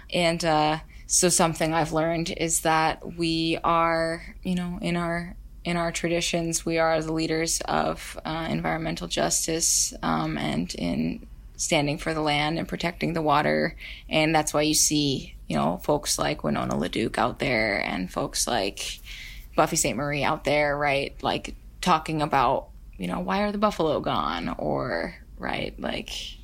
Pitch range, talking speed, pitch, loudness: 150-170 Hz, 160 wpm, 160 Hz, -25 LUFS